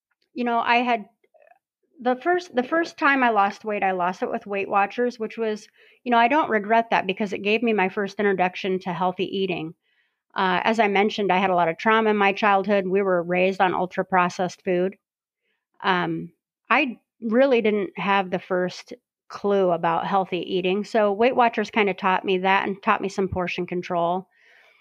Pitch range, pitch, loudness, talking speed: 185-230 Hz, 200 Hz, -22 LUFS, 195 wpm